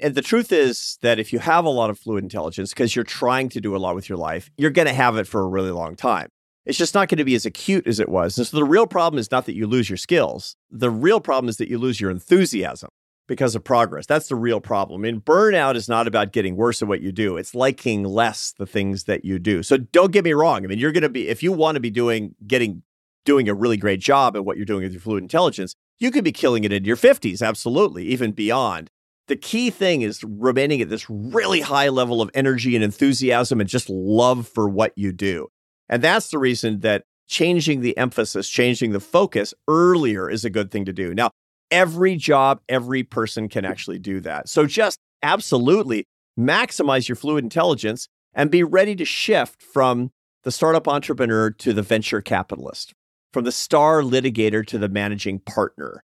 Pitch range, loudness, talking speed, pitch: 105-140 Hz, -20 LUFS, 225 wpm, 120 Hz